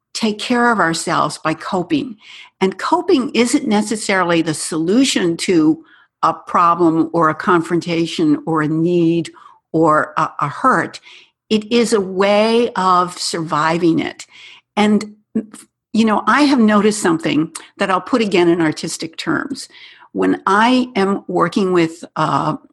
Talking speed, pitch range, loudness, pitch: 140 wpm, 165-235 Hz, -16 LUFS, 195 Hz